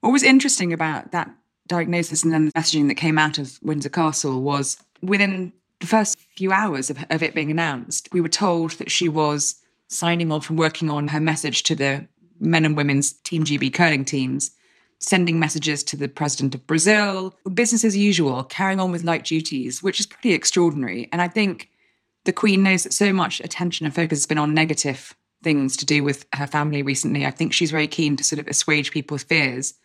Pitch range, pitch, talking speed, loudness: 145-180 Hz, 160 Hz, 205 wpm, -21 LUFS